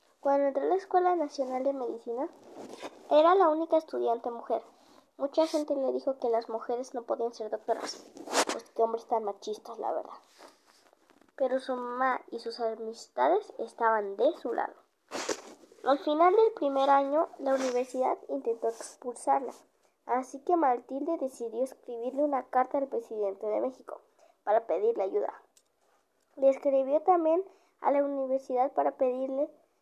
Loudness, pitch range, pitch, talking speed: -30 LUFS, 245-310 Hz, 270 Hz, 145 wpm